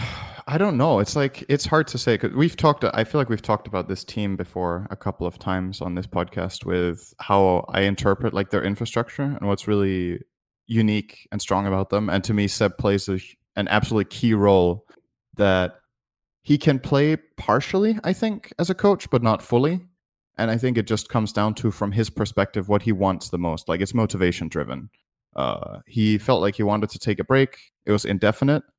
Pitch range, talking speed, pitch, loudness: 95-125 Hz, 205 wpm, 105 Hz, -23 LUFS